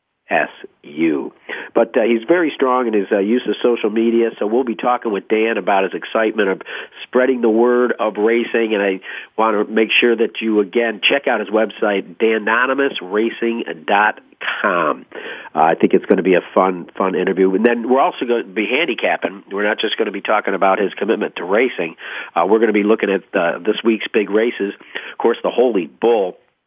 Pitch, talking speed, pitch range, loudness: 115 Hz, 205 wpm, 105-125 Hz, -17 LUFS